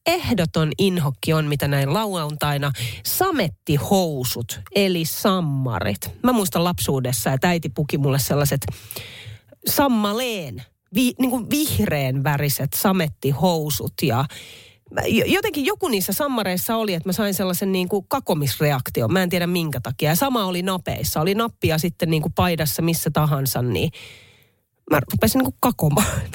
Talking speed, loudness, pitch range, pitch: 130 wpm, -21 LUFS, 135-195 Hz, 160 Hz